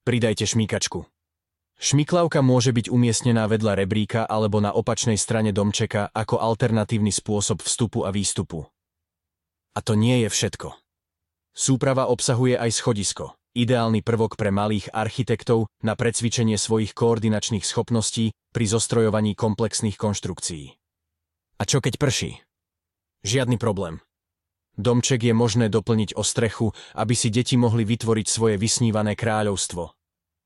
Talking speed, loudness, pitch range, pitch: 120 wpm, -22 LUFS, 100-120 Hz, 110 Hz